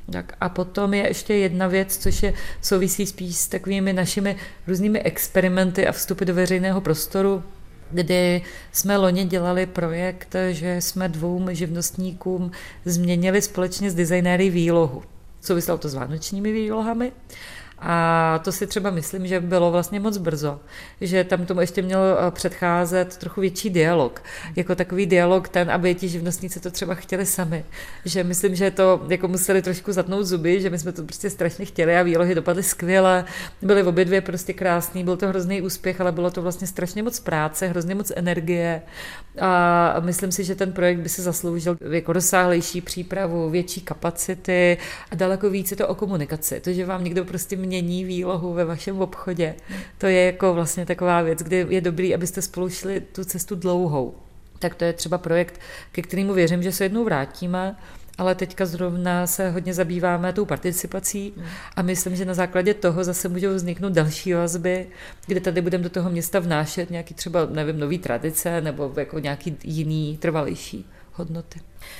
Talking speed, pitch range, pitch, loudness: 170 wpm, 175-190 Hz, 180 Hz, -22 LUFS